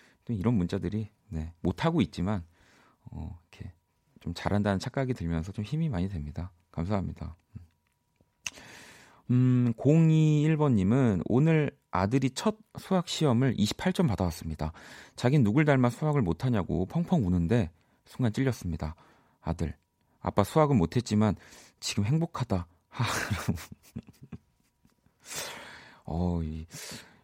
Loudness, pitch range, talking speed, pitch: -29 LUFS, 85-135 Hz, 245 characters per minute, 105 Hz